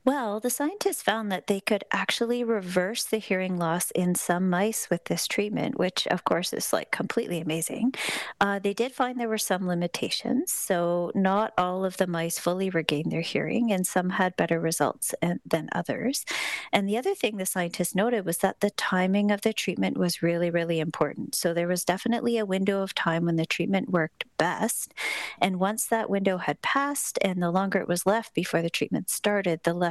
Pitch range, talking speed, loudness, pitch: 175-225 Hz, 200 wpm, -27 LUFS, 190 Hz